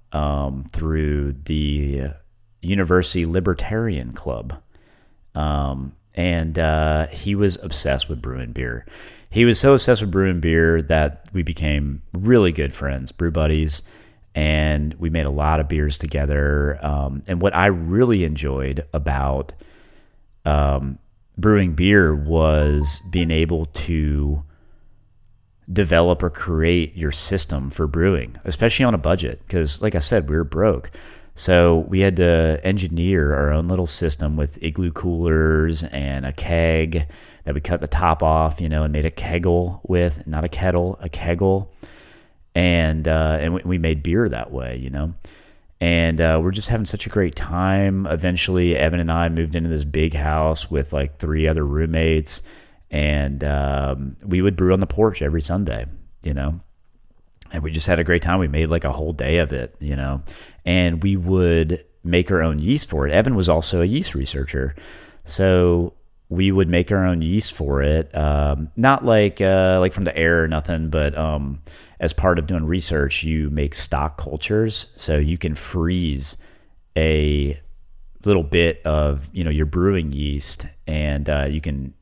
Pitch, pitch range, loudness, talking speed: 80 Hz, 75-90 Hz, -20 LUFS, 165 wpm